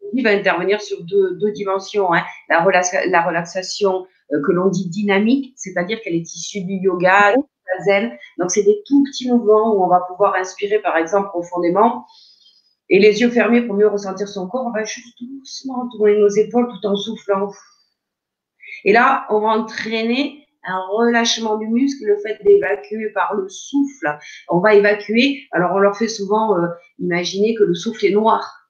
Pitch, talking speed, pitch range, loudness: 210 Hz, 185 wpm, 190-235 Hz, -17 LUFS